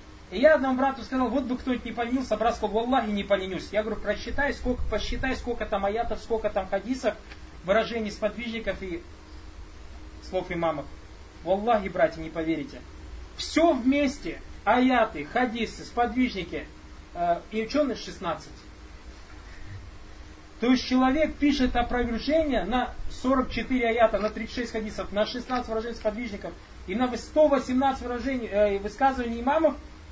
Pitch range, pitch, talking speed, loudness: 170-250 Hz, 220 Hz, 135 wpm, -27 LUFS